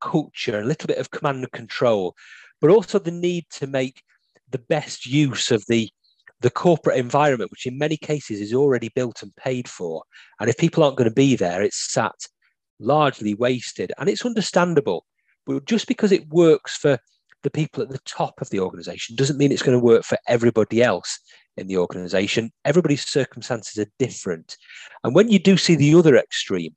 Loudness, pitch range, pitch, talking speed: -21 LUFS, 115-165 Hz, 135 Hz, 190 wpm